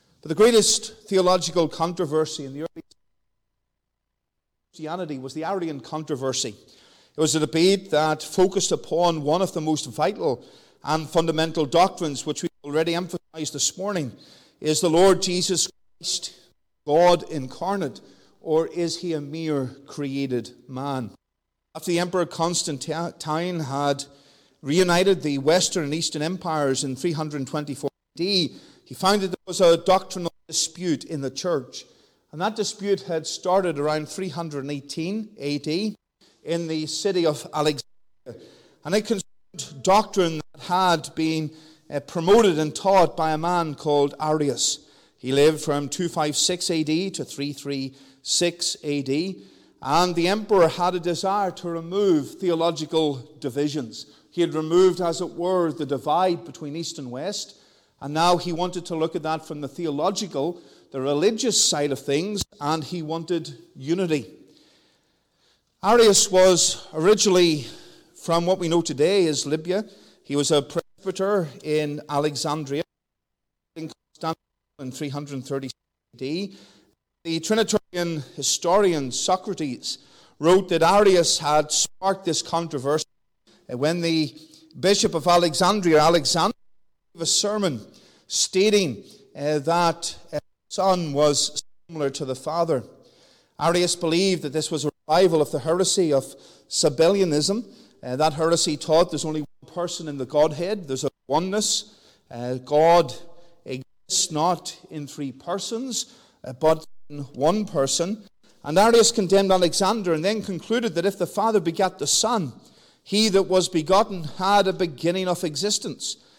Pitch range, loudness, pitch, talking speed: 150-185 Hz, -23 LUFS, 165 Hz, 135 wpm